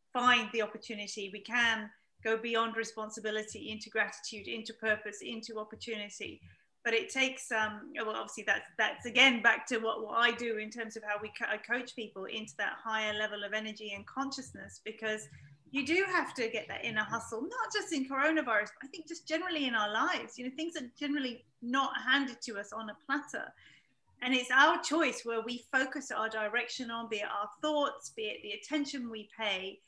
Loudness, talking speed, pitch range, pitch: -33 LUFS, 200 wpm, 215-270 Hz, 230 Hz